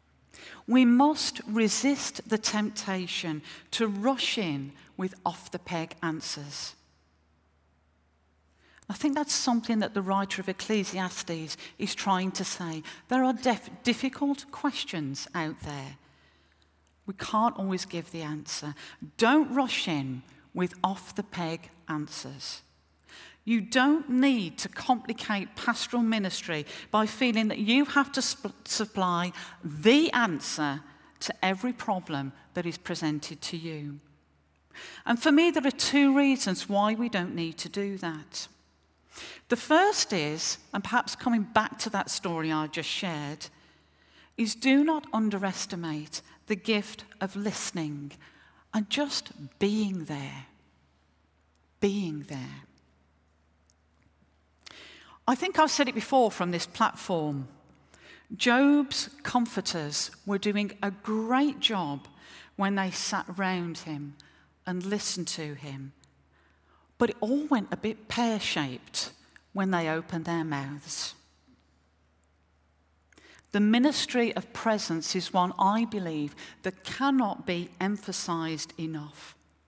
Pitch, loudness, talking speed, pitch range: 185 Hz, -28 LUFS, 125 wpm, 150-225 Hz